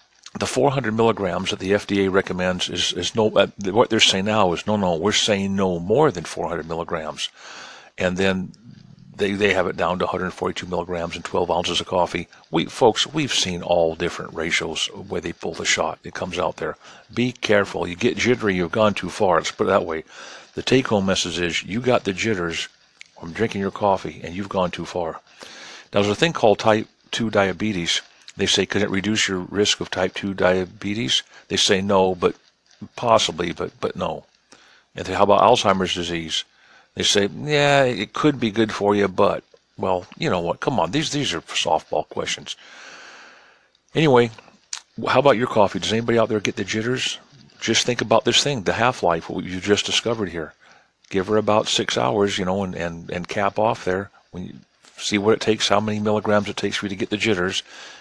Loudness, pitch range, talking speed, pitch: -21 LUFS, 90-110 Hz, 205 wpm, 100 Hz